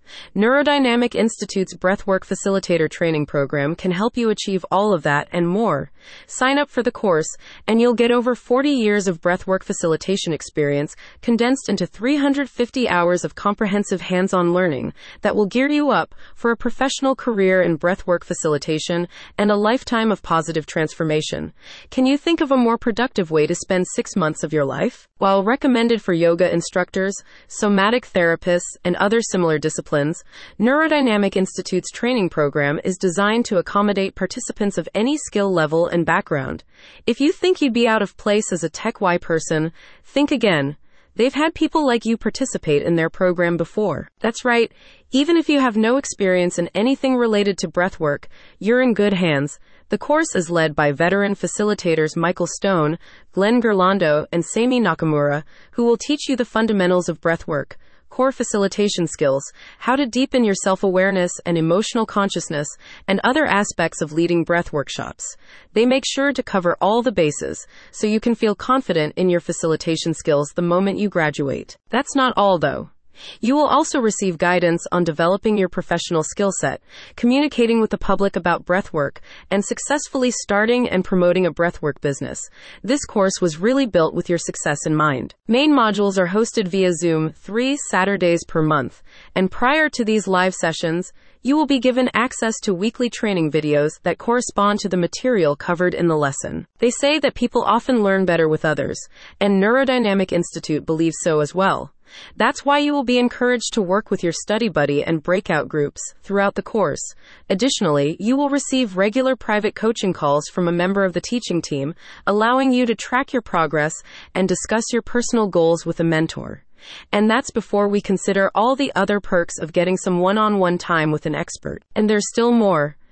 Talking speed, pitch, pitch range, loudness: 175 wpm, 195 Hz, 170-235 Hz, -19 LUFS